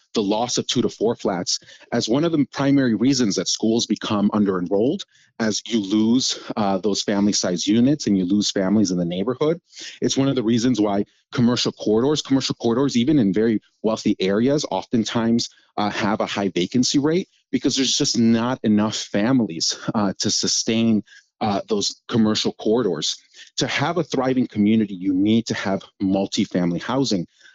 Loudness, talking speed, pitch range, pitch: -21 LUFS, 170 wpm, 105-130 Hz, 110 Hz